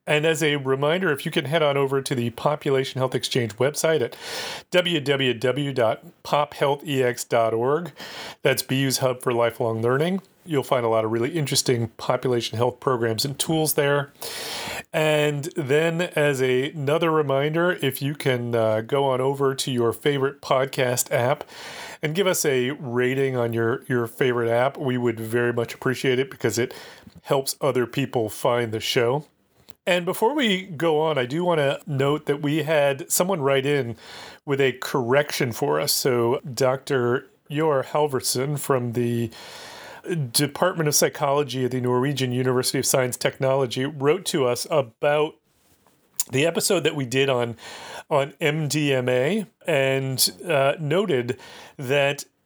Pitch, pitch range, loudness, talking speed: 135 Hz, 125-150 Hz, -23 LUFS, 150 wpm